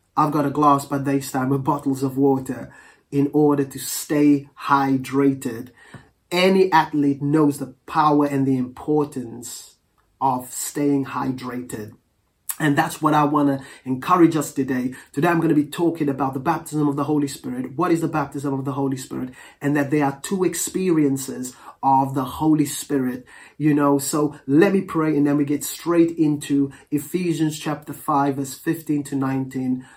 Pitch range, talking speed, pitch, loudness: 135-150 Hz, 170 wpm, 145 Hz, -21 LUFS